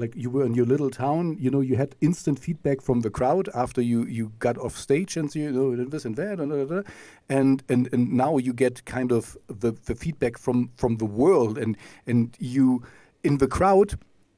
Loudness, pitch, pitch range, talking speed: -25 LUFS, 130 Hz, 120-145 Hz, 205 wpm